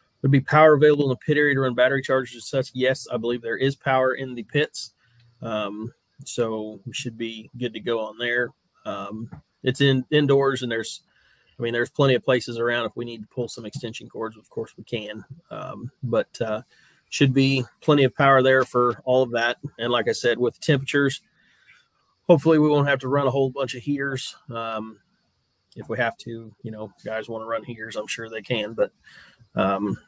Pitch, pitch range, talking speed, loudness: 125 Hz, 115-135 Hz, 210 wpm, -23 LUFS